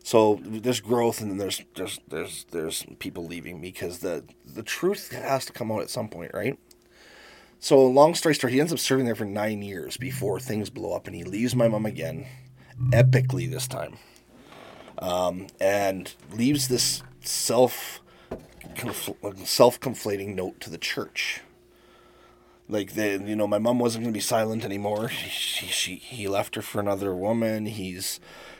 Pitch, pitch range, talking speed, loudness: 115 Hz, 100-130 Hz, 170 wpm, -26 LUFS